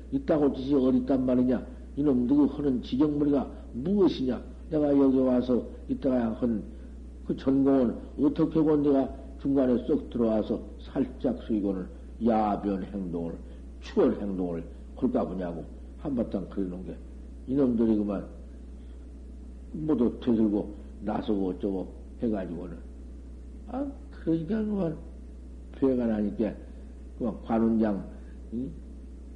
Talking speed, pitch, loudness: 250 characters per minute, 100 Hz, -28 LUFS